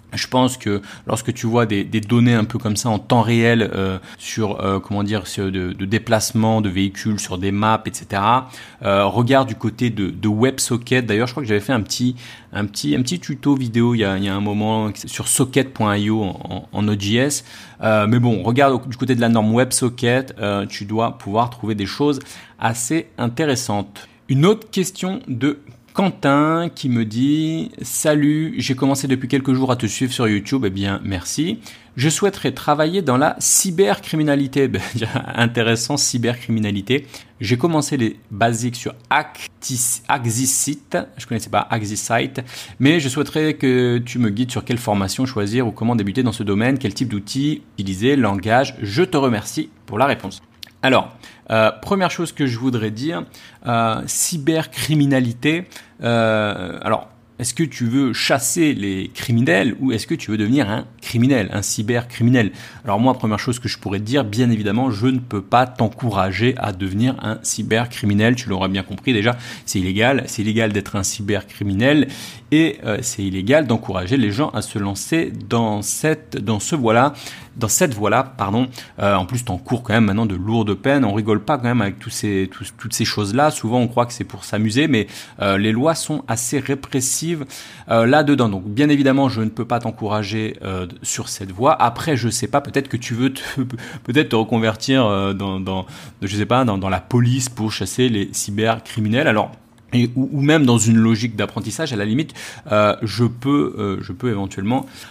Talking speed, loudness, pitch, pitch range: 190 wpm, -19 LUFS, 115 Hz, 105-130 Hz